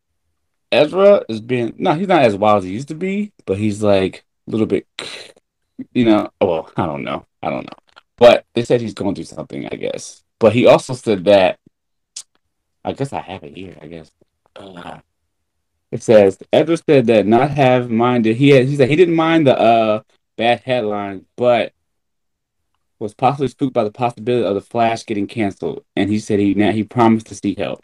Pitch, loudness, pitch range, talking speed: 110 Hz, -16 LUFS, 100-130 Hz, 195 wpm